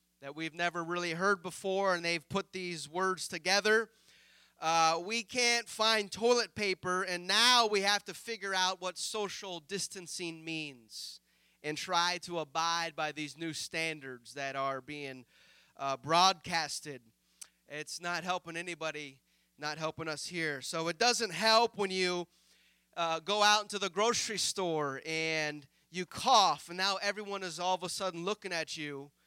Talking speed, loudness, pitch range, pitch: 160 wpm, -32 LUFS, 155-195 Hz, 175 Hz